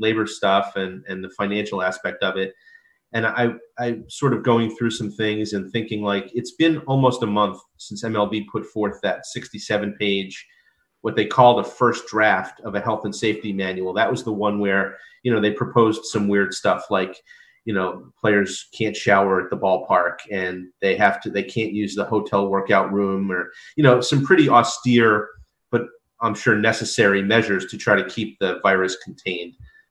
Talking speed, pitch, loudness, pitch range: 195 wpm, 105 Hz, -21 LUFS, 100-115 Hz